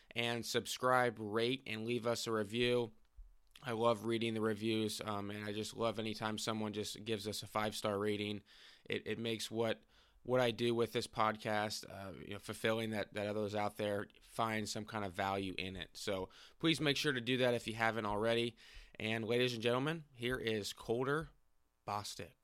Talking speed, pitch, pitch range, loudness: 195 wpm, 110 Hz, 105-120 Hz, -38 LUFS